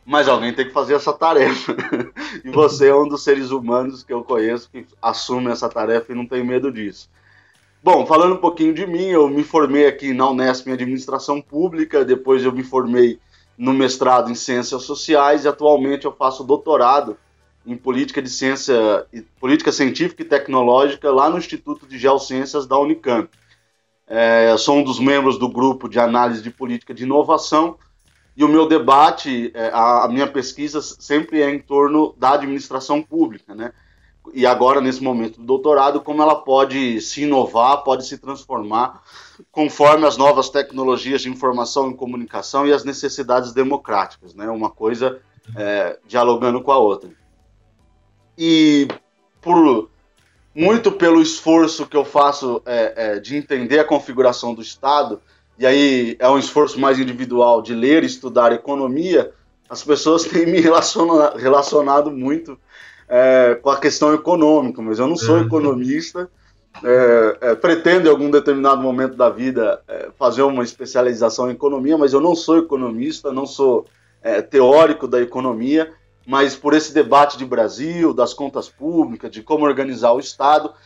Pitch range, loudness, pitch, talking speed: 125-150 Hz, -16 LUFS, 135 Hz, 165 wpm